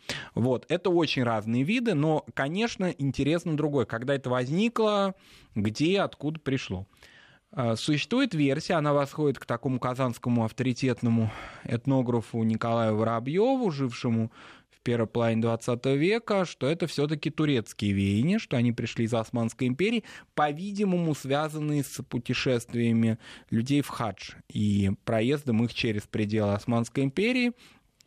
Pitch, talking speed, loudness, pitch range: 130 Hz, 125 wpm, -28 LUFS, 115-155 Hz